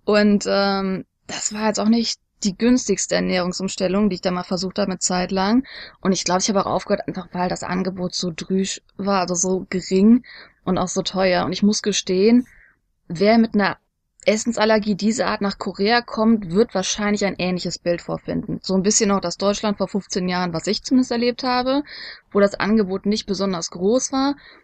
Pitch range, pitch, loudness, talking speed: 185-215 Hz, 195 Hz, -20 LUFS, 190 wpm